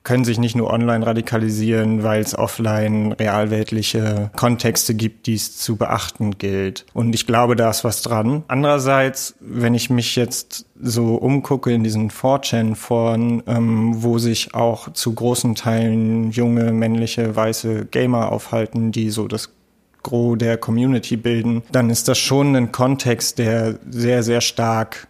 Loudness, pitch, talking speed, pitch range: -19 LUFS, 115 Hz, 150 wpm, 110-120 Hz